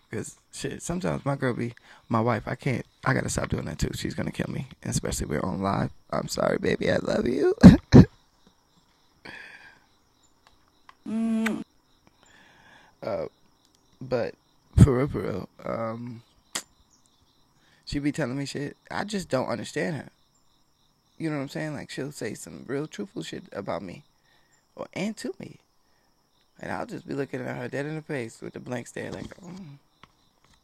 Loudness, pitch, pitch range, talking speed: -26 LUFS, 140 Hz, 130-175 Hz, 170 wpm